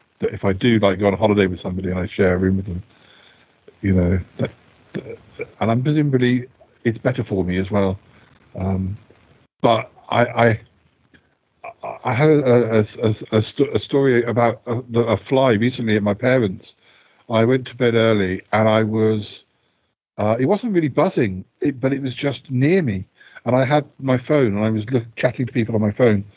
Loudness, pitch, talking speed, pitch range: -19 LUFS, 115 Hz, 200 wpm, 100-130 Hz